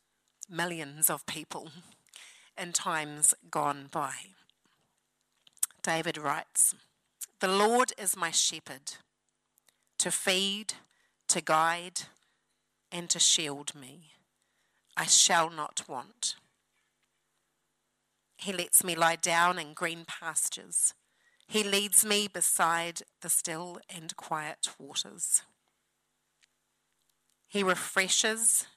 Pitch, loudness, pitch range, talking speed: 175 Hz, -28 LUFS, 160-200 Hz, 95 wpm